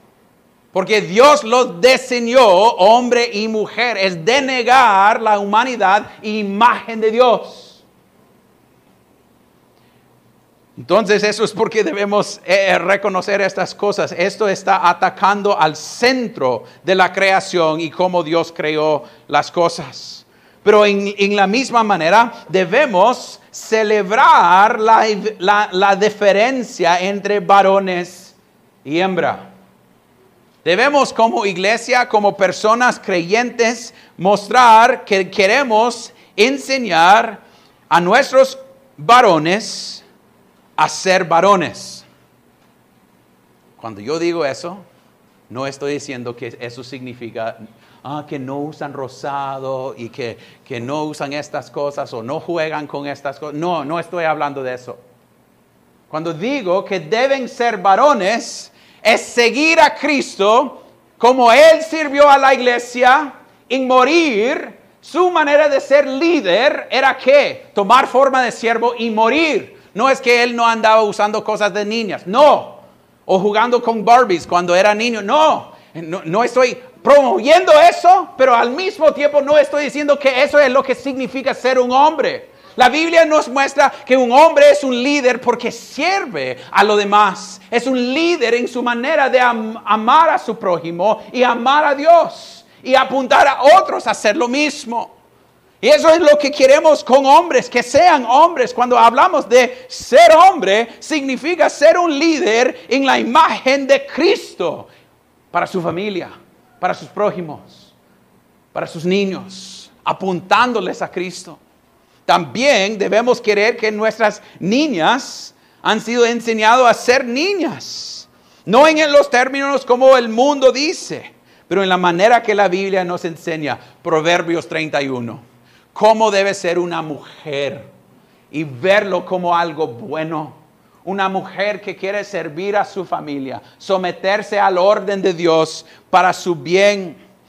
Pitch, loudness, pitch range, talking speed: 215 Hz, -14 LUFS, 180-260 Hz, 135 wpm